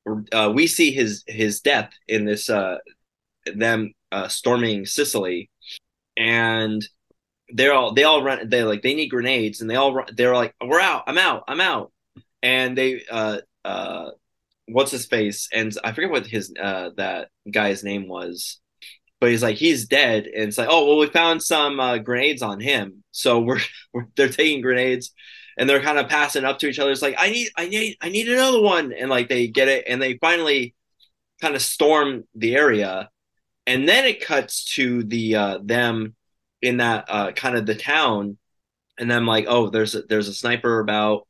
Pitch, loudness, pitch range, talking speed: 120 Hz, -20 LUFS, 110-135 Hz, 195 wpm